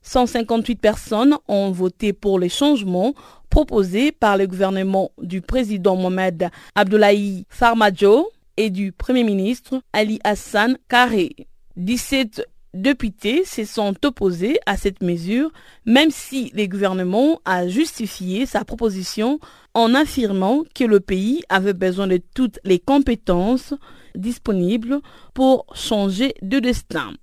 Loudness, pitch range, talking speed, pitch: -19 LUFS, 195-260 Hz, 120 wpm, 215 Hz